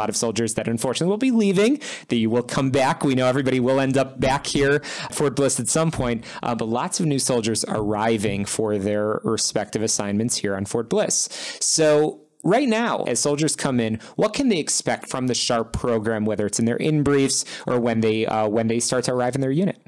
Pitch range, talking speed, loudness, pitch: 115-145 Hz, 225 wpm, -21 LUFS, 125 Hz